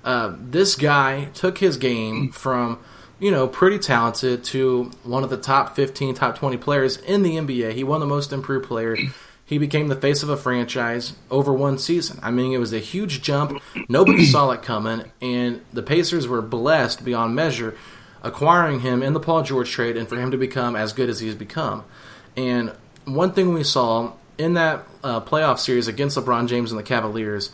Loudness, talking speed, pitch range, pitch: -21 LUFS, 195 wpm, 120-145 Hz, 130 Hz